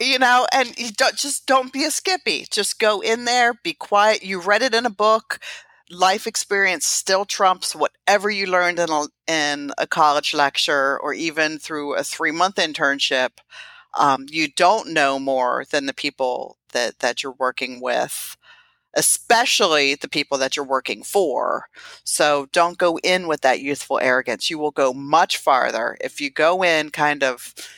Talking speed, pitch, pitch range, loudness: 175 wpm, 165 Hz, 140-210 Hz, -19 LUFS